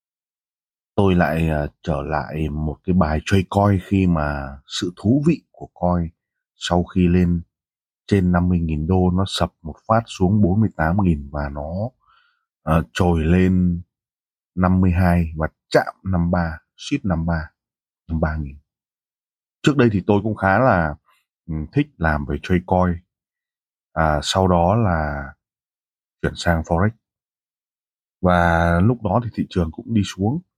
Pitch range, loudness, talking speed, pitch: 80-95 Hz, -20 LUFS, 135 wpm, 90 Hz